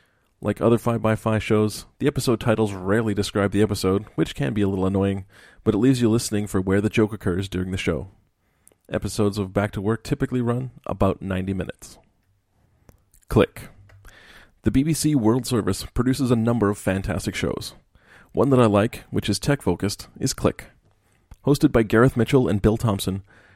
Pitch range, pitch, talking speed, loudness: 95-115 Hz, 105 Hz, 175 wpm, -22 LUFS